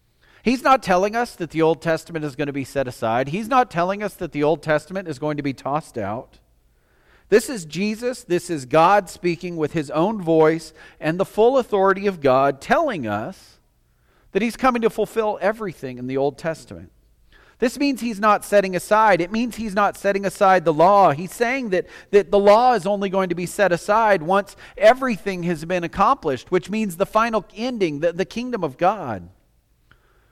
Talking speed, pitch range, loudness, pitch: 195 wpm, 160-215 Hz, -20 LUFS, 190 Hz